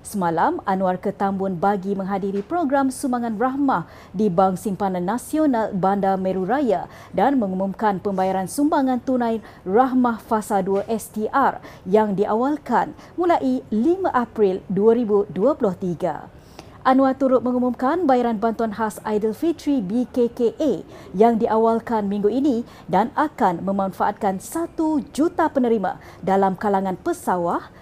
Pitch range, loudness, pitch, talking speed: 195-260 Hz, -21 LUFS, 220 Hz, 110 wpm